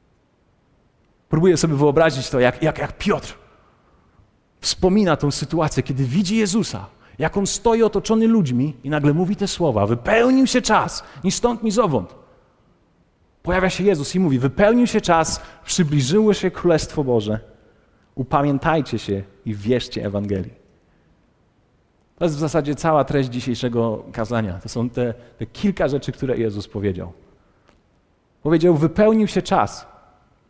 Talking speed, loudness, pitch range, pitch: 135 wpm, -19 LUFS, 120-185 Hz, 150 Hz